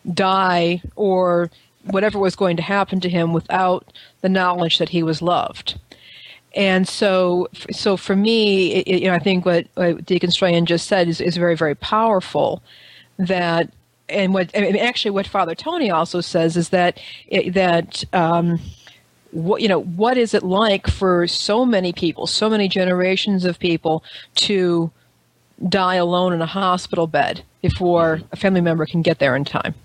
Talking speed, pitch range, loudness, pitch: 170 wpm, 170-195 Hz, -18 LUFS, 180 Hz